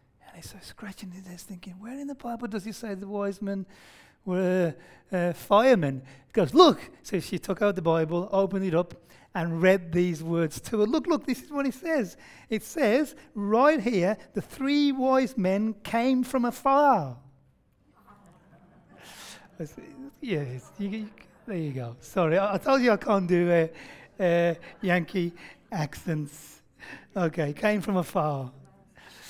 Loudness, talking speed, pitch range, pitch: -26 LUFS, 160 wpm, 170-230 Hz, 195 Hz